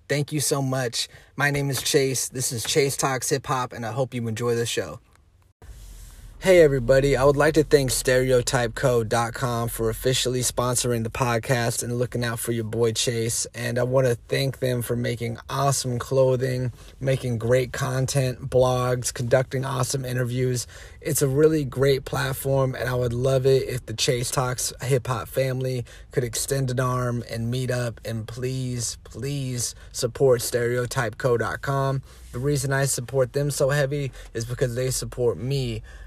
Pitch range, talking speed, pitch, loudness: 120-135 Hz, 165 wpm, 125 Hz, -24 LUFS